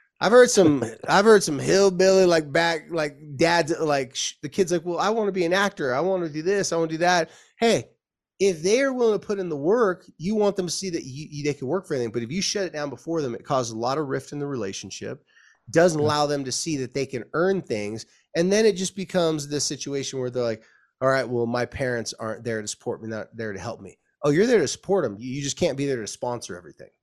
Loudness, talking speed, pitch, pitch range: -23 LUFS, 270 wpm, 155 Hz, 130-185 Hz